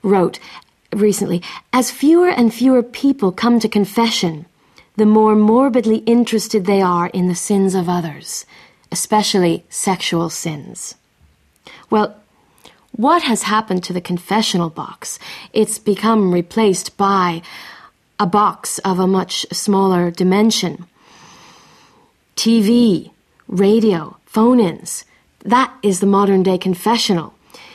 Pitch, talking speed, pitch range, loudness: 200 Hz, 115 wpm, 180-225 Hz, -16 LUFS